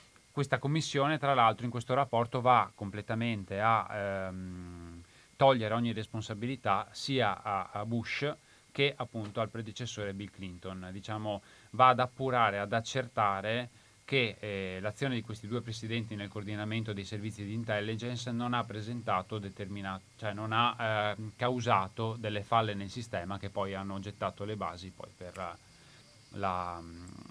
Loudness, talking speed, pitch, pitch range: -33 LUFS, 145 wpm, 110 Hz, 100-120 Hz